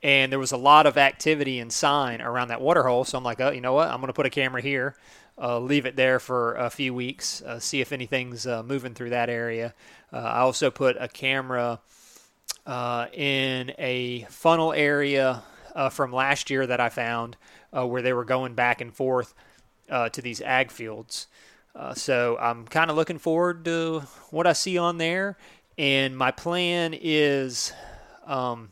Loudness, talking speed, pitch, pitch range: -25 LUFS, 195 wpm, 130 Hz, 120-145 Hz